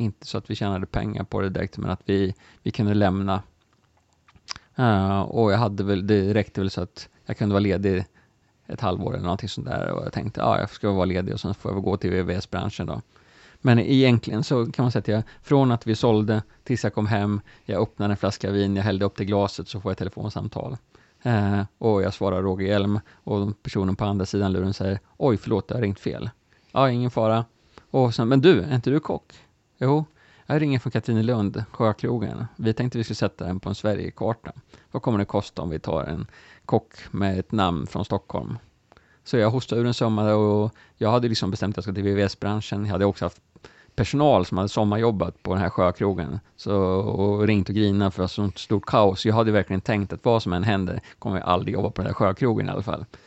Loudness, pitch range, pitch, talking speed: -24 LUFS, 95-115 Hz, 105 Hz, 230 wpm